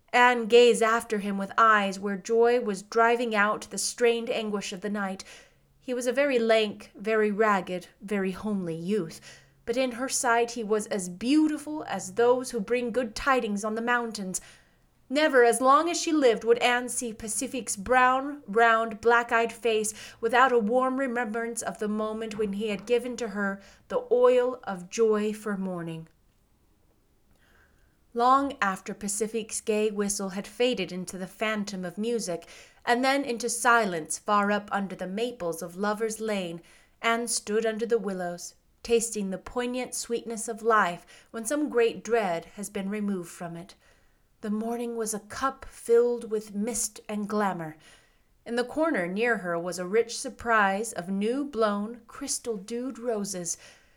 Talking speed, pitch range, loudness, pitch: 165 wpm, 200-240 Hz, -27 LUFS, 225 Hz